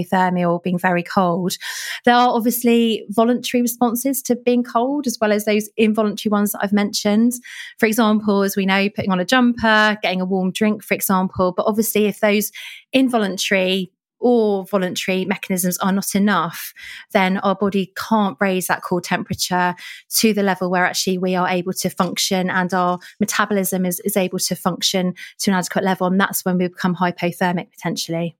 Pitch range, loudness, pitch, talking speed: 185-220 Hz, -19 LUFS, 195 Hz, 180 wpm